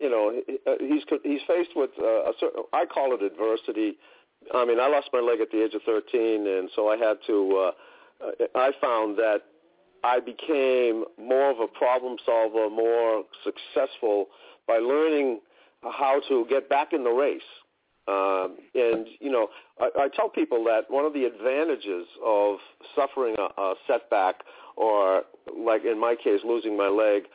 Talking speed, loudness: 165 wpm, -25 LUFS